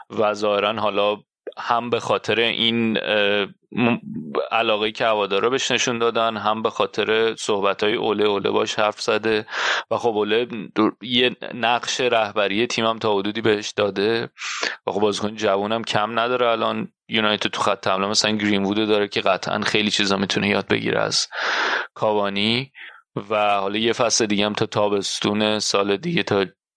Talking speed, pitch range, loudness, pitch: 160 wpm, 105-115 Hz, -21 LUFS, 105 Hz